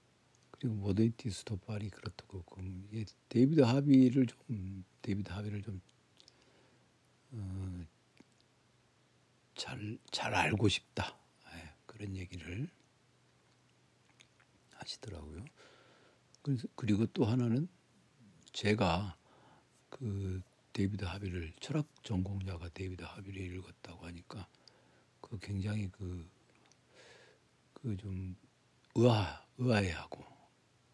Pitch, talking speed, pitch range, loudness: 100 Hz, 190 characters per minute, 95-115 Hz, -36 LUFS